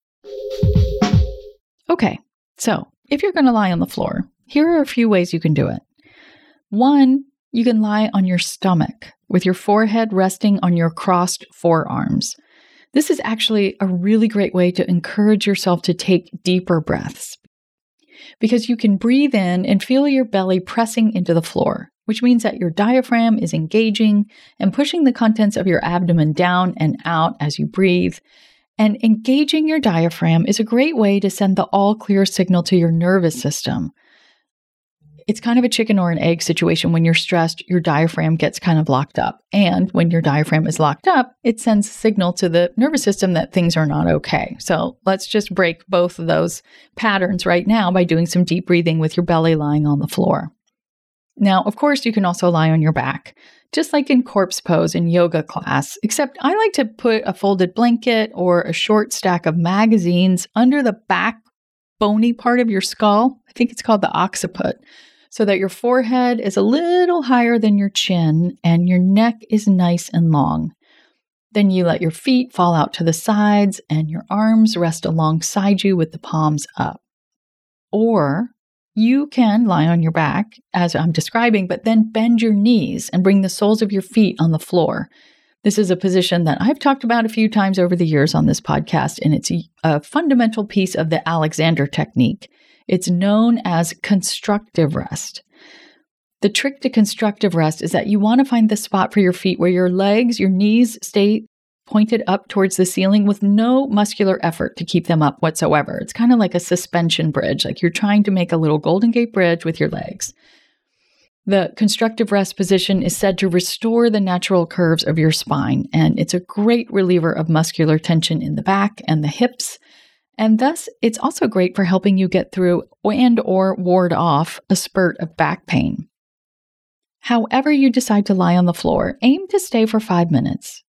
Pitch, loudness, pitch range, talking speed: 200 Hz, -17 LUFS, 175-230 Hz, 190 wpm